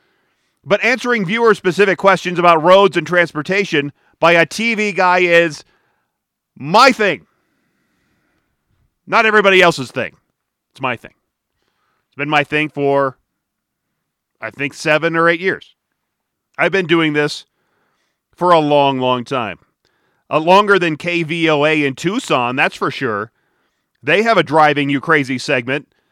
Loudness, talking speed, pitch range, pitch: -14 LUFS, 135 wpm, 145-190 Hz, 170 Hz